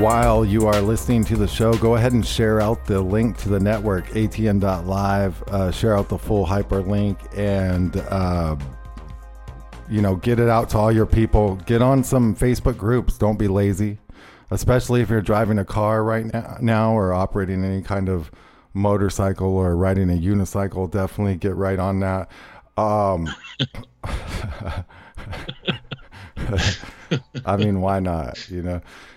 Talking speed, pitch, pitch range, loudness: 150 wpm, 100 Hz, 95-110 Hz, -21 LUFS